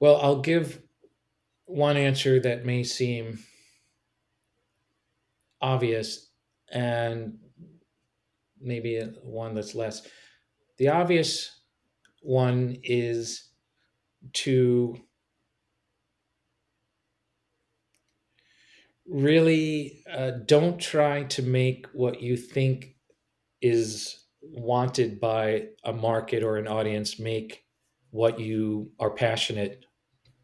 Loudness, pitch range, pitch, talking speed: -26 LUFS, 115-135 Hz, 125 Hz, 80 wpm